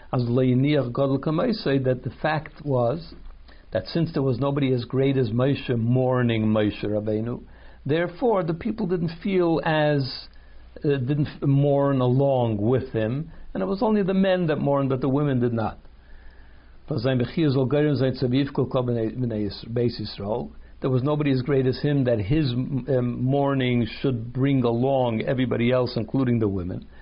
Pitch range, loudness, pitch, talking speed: 115-145 Hz, -24 LUFS, 130 Hz, 135 wpm